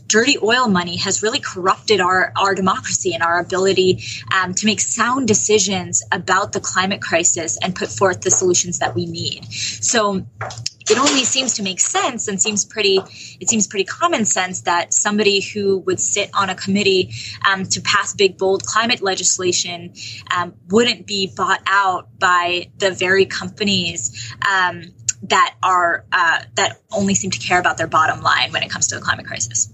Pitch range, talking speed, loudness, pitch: 175-210 Hz, 180 wpm, -17 LUFS, 190 Hz